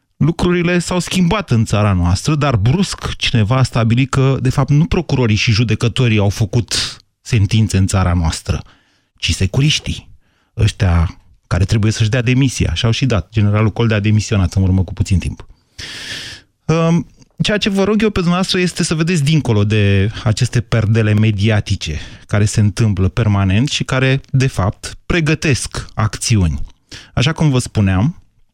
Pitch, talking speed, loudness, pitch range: 110 Hz, 155 wpm, -15 LUFS, 100-135 Hz